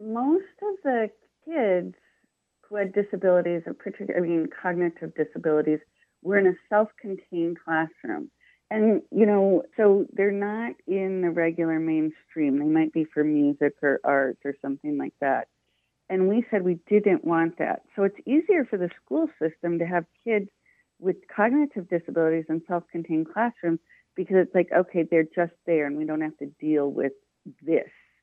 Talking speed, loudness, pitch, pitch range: 165 wpm, -25 LUFS, 175 Hz, 160-210 Hz